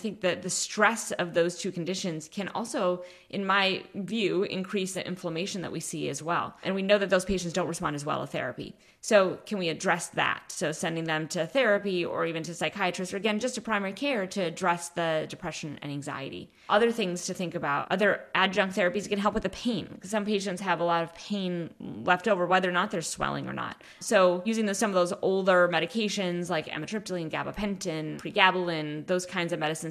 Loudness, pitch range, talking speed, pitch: -28 LUFS, 170-200 Hz, 210 wpm, 180 Hz